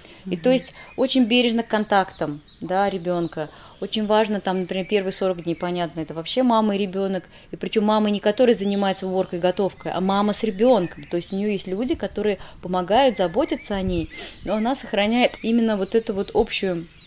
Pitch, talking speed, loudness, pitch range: 200 Hz, 185 wpm, -22 LUFS, 180-220 Hz